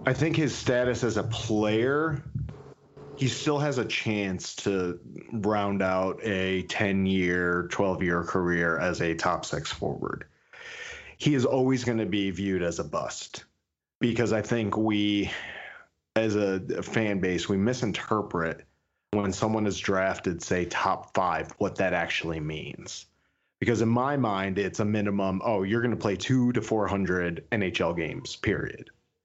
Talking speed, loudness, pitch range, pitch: 155 wpm, -28 LUFS, 95-125 Hz, 105 Hz